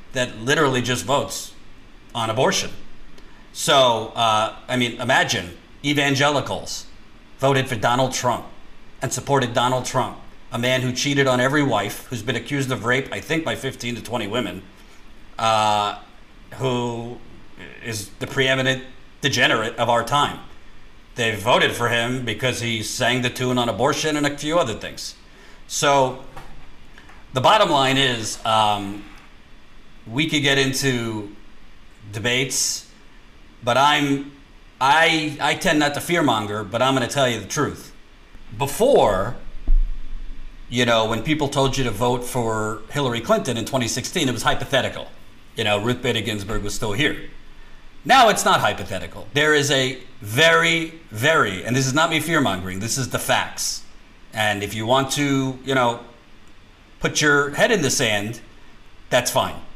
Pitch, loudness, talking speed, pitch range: 125 Hz, -20 LUFS, 150 wpm, 110-135 Hz